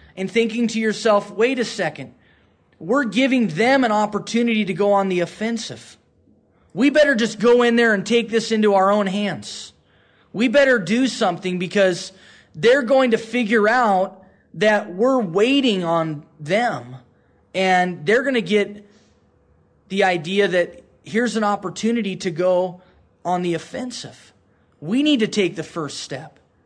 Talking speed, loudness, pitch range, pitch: 155 wpm, -19 LUFS, 175-230 Hz, 205 Hz